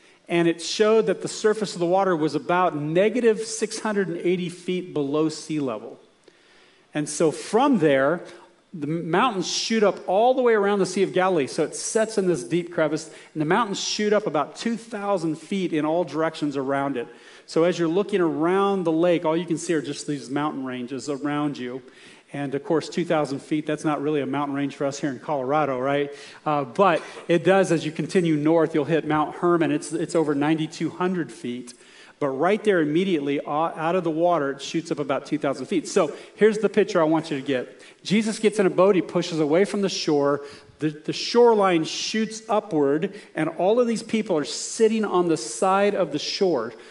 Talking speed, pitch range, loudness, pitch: 200 wpm, 150-195 Hz, -23 LUFS, 165 Hz